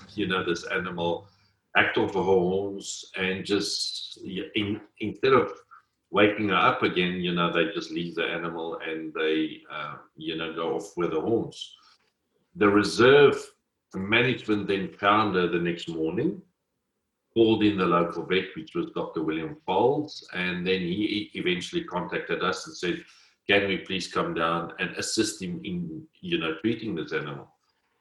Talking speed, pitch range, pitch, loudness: 160 wpm, 85-115 Hz, 95 Hz, -26 LUFS